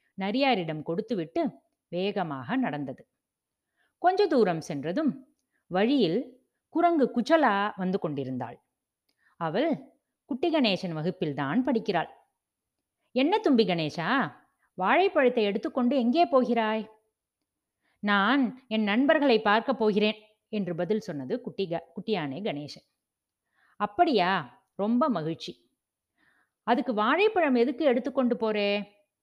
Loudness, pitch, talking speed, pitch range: -27 LUFS, 220 Hz, 90 wpm, 195-270 Hz